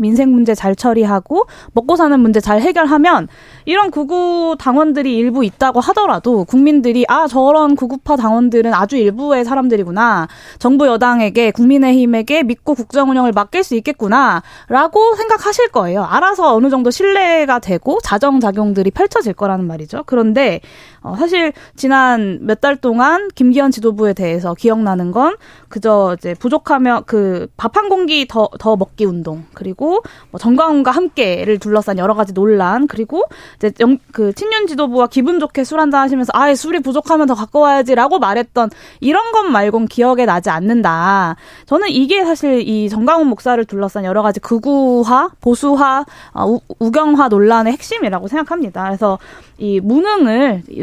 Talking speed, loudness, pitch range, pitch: 350 characters per minute, -13 LUFS, 215-295 Hz, 250 Hz